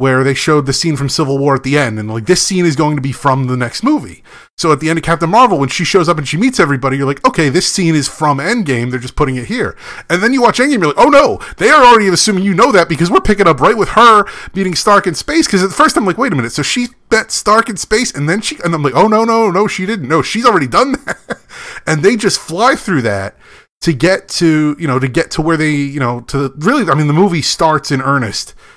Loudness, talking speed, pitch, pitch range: -12 LUFS, 285 wpm, 170 Hz, 140-210 Hz